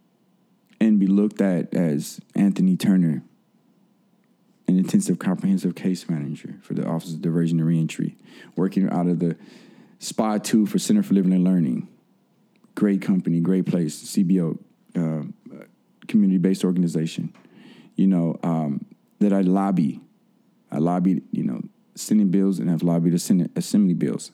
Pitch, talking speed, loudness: 100 Hz, 140 wpm, -22 LUFS